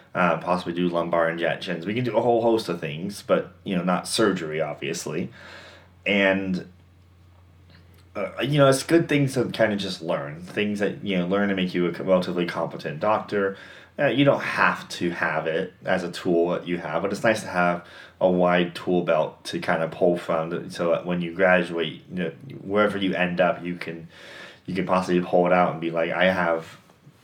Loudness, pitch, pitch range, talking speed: -24 LUFS, 90 Hz, 85-95 Hz, 205 wpm